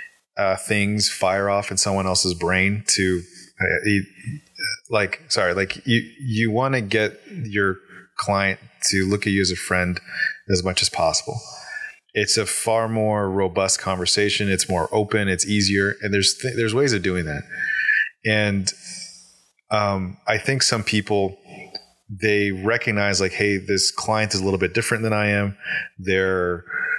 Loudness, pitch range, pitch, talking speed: -21 LUFS, 95-110 Hz, 100 Hz, 160 wpm